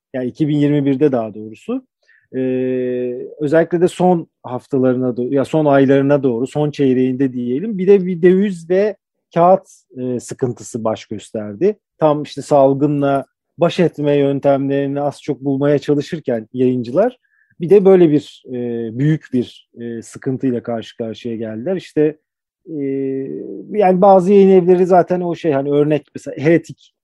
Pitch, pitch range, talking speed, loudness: 140 Hz, 125-170 Hz, 140 wpm, -16 LUFS